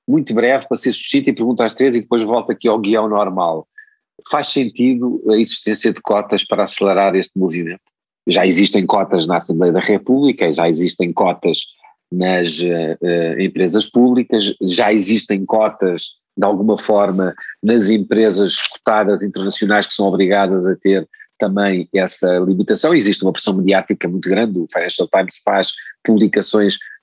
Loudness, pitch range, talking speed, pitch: -15 LUFS, 95-110 Hz, 155 wpm, 100 Hz